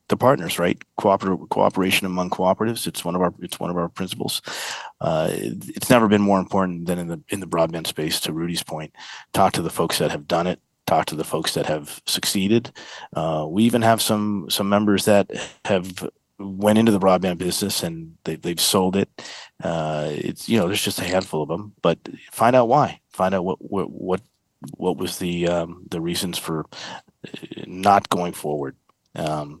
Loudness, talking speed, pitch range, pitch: -22 LUFS, 195 wpm, 85-100 Hz, 95 Hz